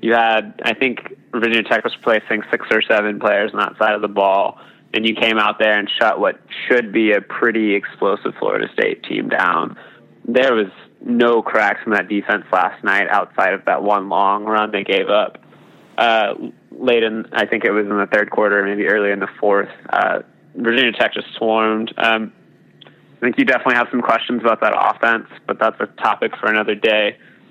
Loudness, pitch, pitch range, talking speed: -17 LUFS, 110 Hz, 105-115 Hz, 200 wpm